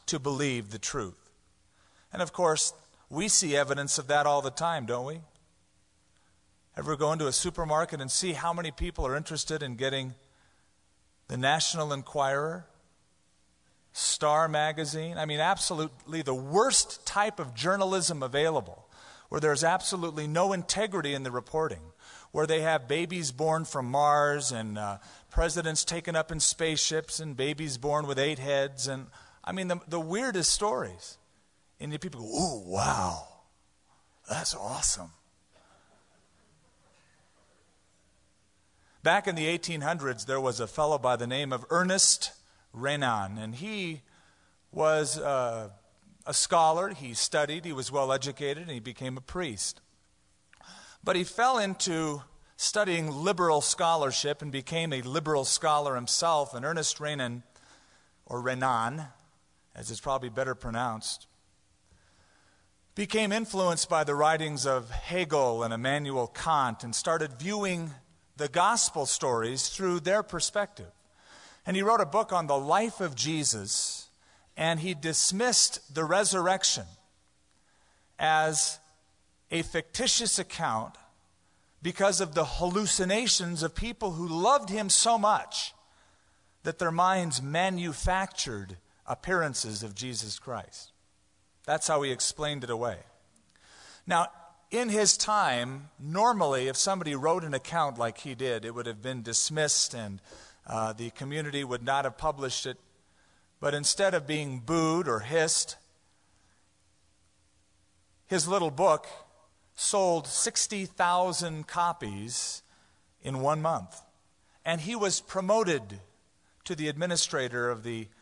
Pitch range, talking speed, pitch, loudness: 120-170 Hz, 130 wpm, 150 Hz, -29 LUFS